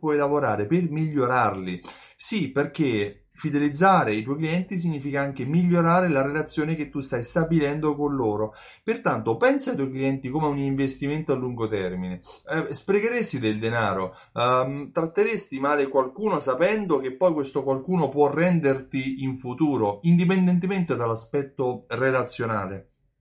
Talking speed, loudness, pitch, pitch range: 135 wpm, -24 LUFS, 140 Hz, 125-165 Hz